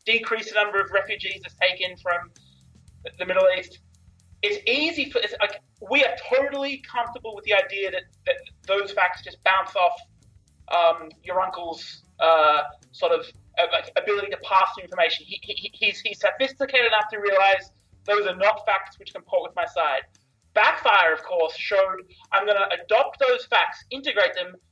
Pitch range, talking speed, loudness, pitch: 175-225 Hz, 175 wpm, -23 LUFS, 195 Hz